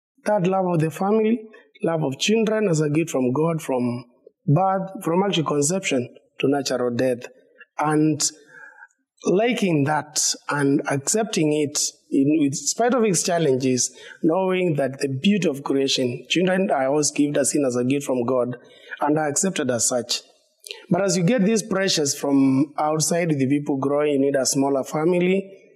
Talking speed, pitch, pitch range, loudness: 160 wpm, 155 Hz, 140-195 Hz, -21 LUFS